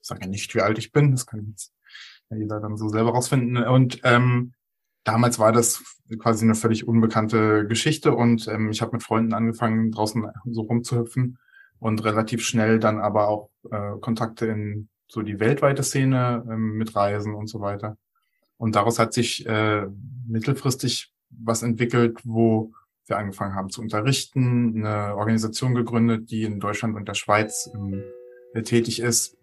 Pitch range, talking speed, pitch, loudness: 110-120 Hz, 160 wpm, 115 Hz, -23 LUFS